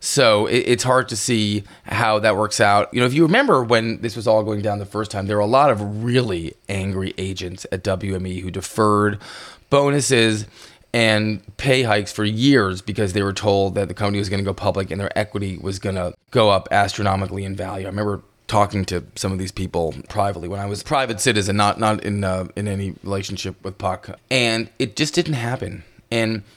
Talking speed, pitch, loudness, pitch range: 210 wpm, 105 Hz, -20 LUFS, 95-115 Hz